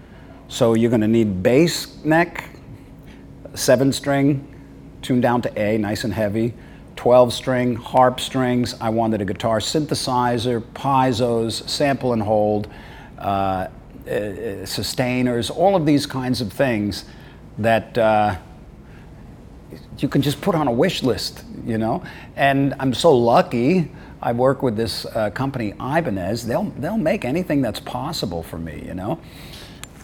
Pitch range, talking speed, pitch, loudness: 110-135 Hz, 140 wpm, 120 Hz, -20 LUFS